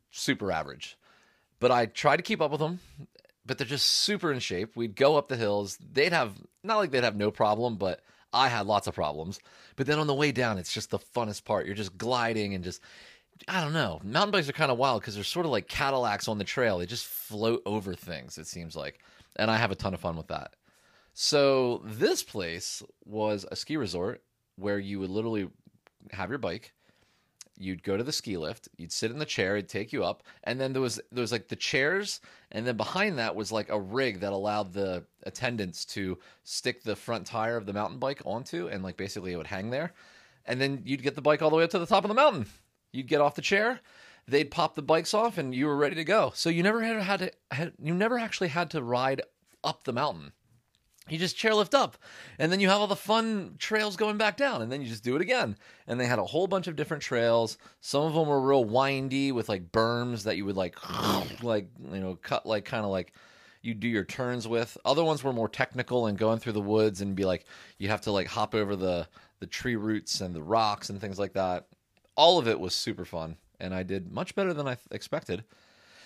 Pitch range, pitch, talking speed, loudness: 100-150 Hz, 120 Hz, 240 wpm, -29 LUFS